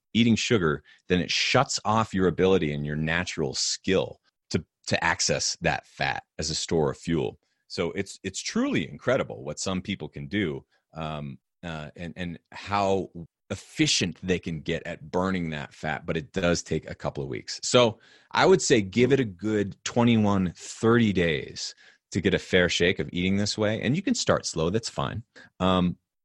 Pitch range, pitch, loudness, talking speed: 85-105 Hz, 90 Hz, -26 LUFS, 185 wpm